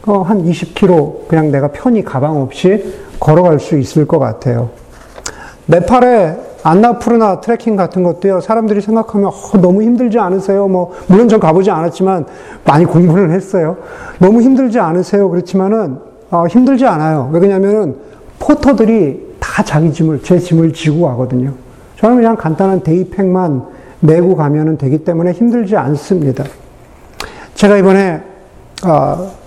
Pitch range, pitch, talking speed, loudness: 160-210 Hz, 185 Hz, 315 characters per minute, -11 LUFS